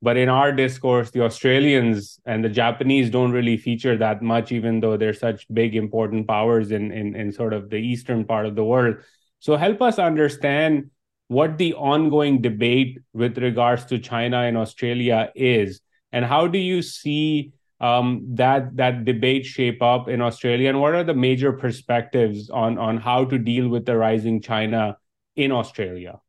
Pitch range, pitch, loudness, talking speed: 115-135 Hz, 120 Hz, -21 LUFS, 175 wpm